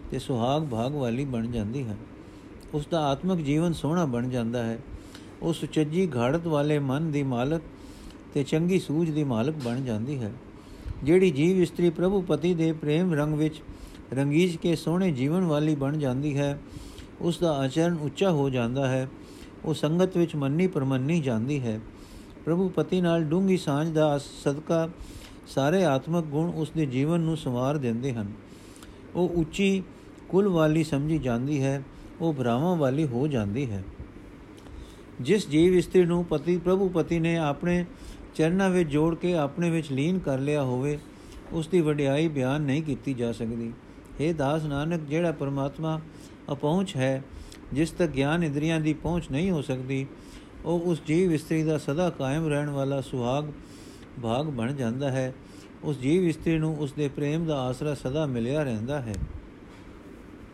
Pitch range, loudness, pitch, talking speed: 130-165 Hz, -27 LUFS, 150 Hz, 160 wpm